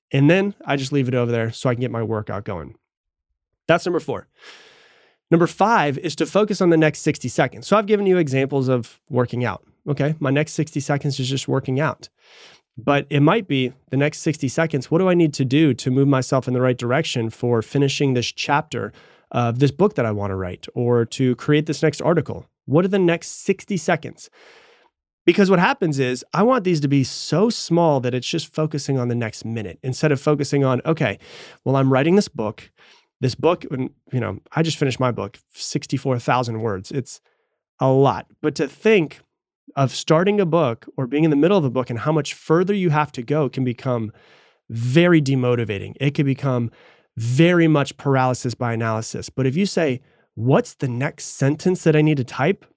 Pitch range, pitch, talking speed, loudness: 125-160 Hz, 140 Hz, 205 wpm, -20 LUFS